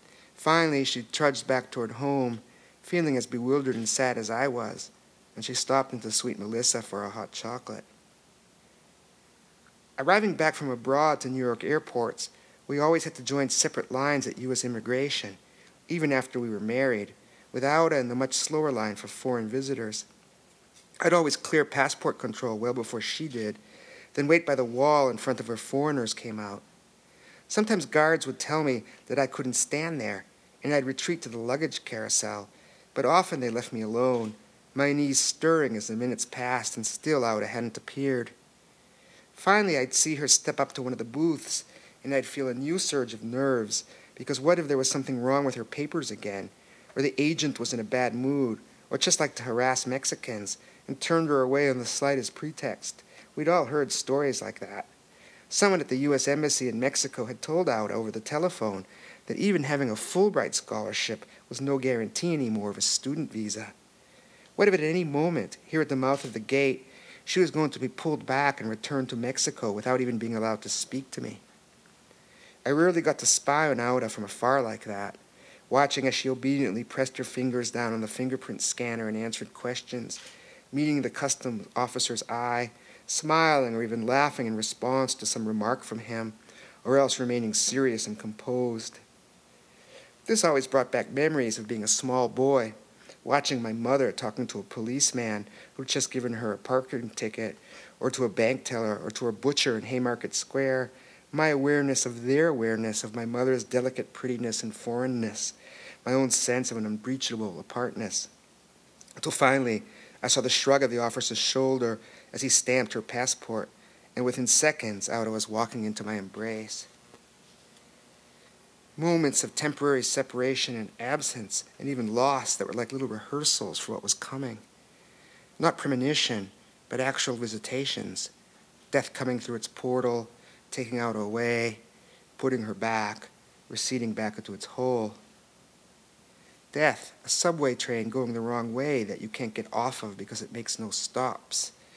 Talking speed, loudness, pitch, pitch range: 175 wpm, -28 LUFS, 125 Hz, 115-140 Hz